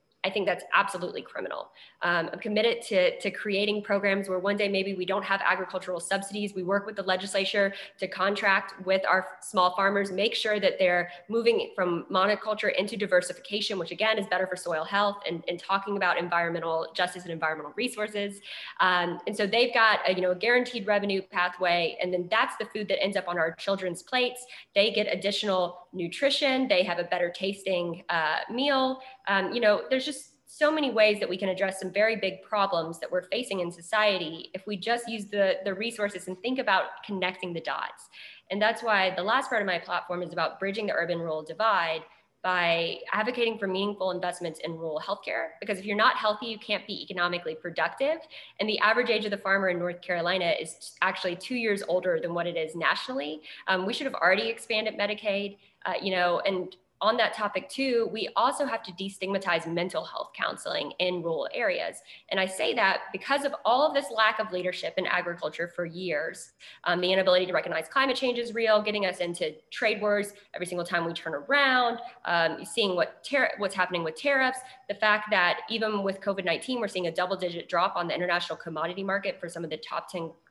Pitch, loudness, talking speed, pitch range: 195 Hz, -28 LUFS, 205 wpm, 180-215 Hz